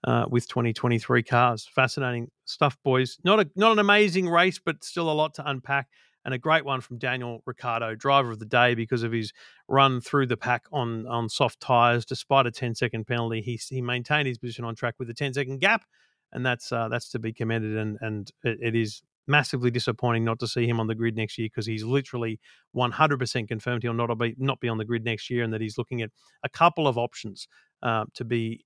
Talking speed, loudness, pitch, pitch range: 225 wpm, -26 LUFS, 120 Hz, 115-135 Hz